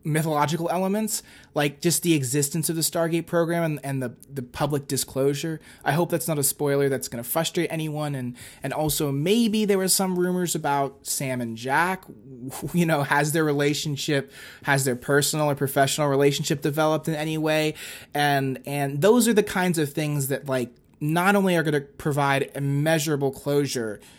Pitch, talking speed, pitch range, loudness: 150 Hz, 175 wpm, 140-165 Hz, -24 LUFS